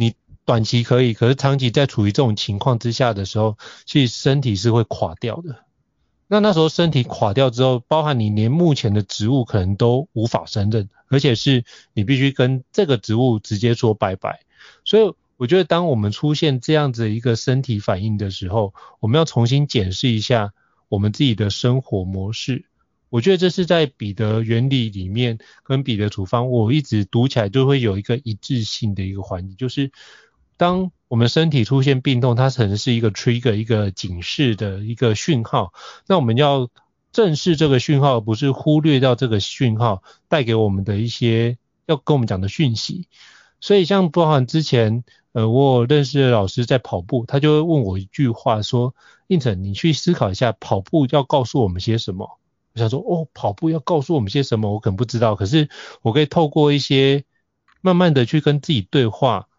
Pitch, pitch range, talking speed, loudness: 125 Hz, 110-145 Hz, 295 characters per minute, -19 LUFS